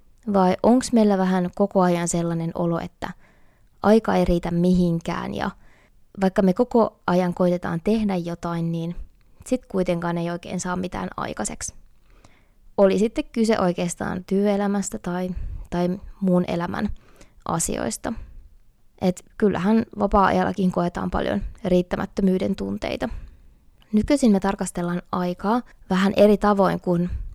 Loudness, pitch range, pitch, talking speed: -23 LUFS, 175-205 Hz, 185 Hz, 120 wpm